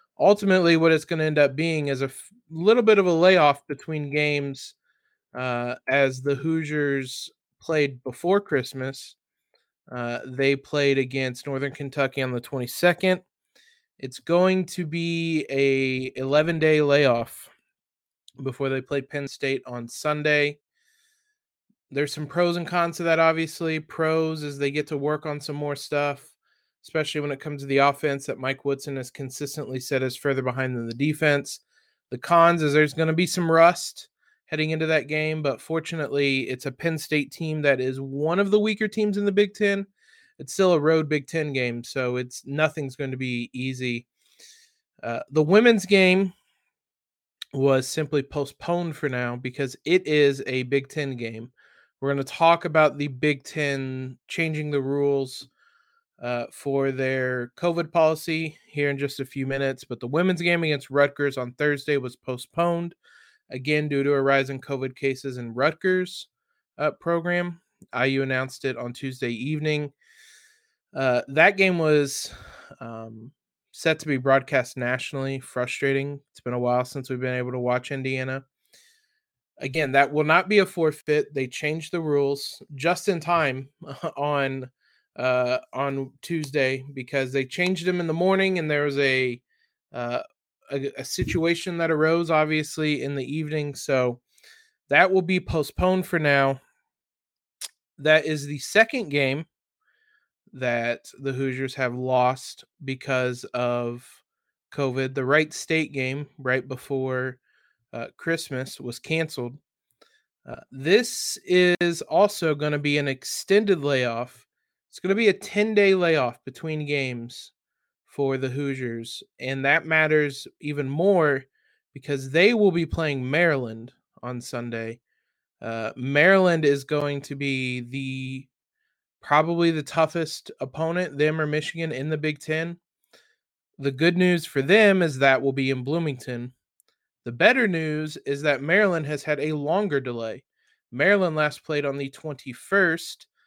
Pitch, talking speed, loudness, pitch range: 145 Hz, 155 wpm, -24 LUFS, 135-165 Hz